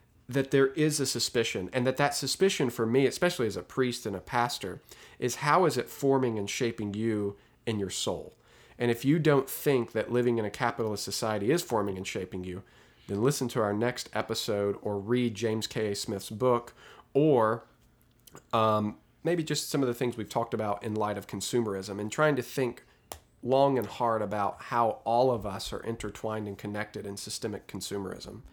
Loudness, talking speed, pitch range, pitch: -30 LUFS, 195 wpm, 105-130 Hz, 115 Hz